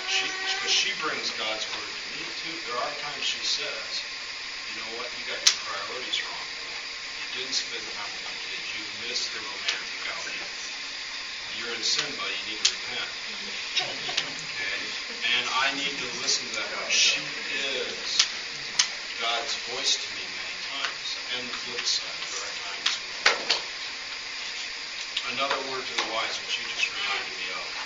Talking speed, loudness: 165 wpm, -27 LUFS